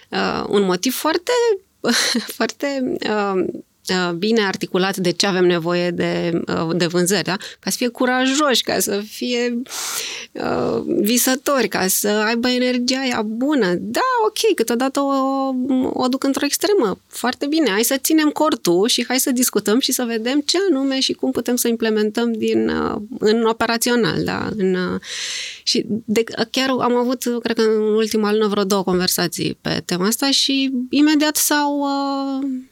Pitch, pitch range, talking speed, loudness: 240 Hz, 210-275 Hz, 155 wpm, -19 LUFS